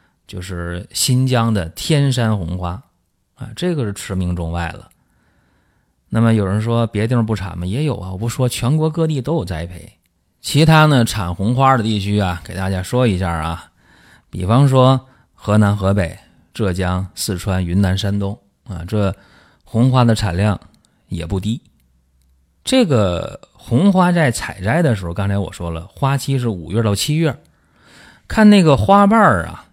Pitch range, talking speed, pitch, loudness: 90-130 Hz, 230 characters per minute, 105 Hz, -17 LUFS